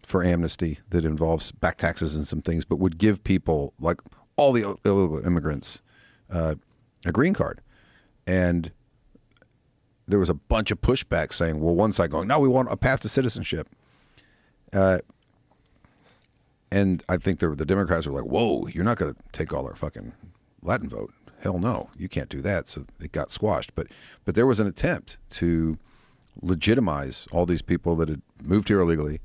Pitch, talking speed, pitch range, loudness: 90 Hz, 180 wpm, 85-110 Hz, -25 LUFS